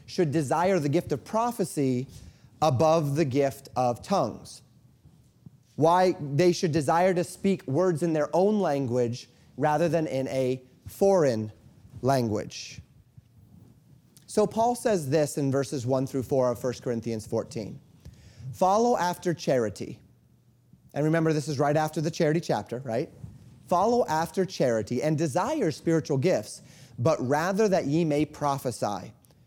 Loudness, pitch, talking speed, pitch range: -26 LUFS, 150 Hz, 135 wpm, 130-175 Hz